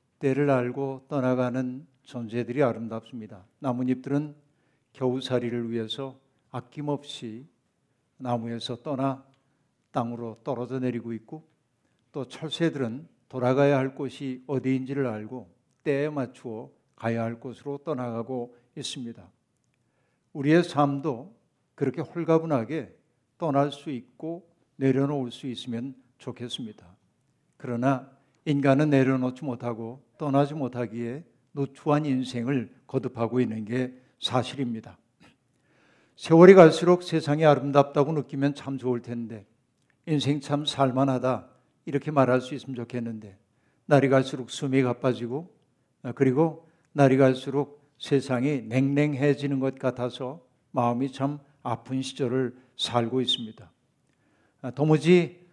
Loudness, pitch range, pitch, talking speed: -26 LUFS, 120-145 Hz, 135 Hz, 270 characters per minute